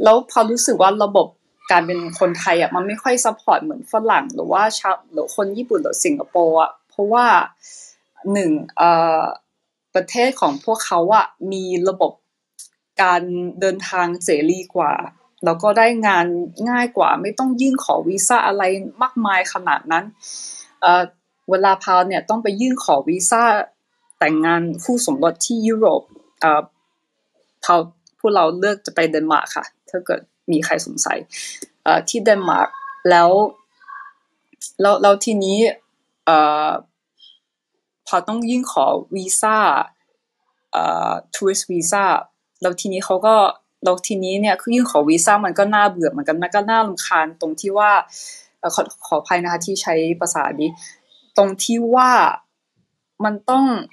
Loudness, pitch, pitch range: -17 LUFS, 200 Hz, 180-240 Hz